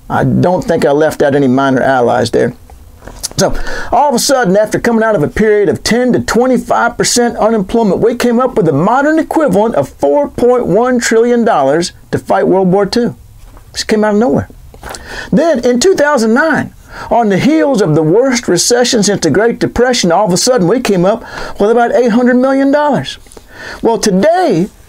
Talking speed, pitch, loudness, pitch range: 195 wpm, 225 Hz, -10 LUFS, 180-245 Hz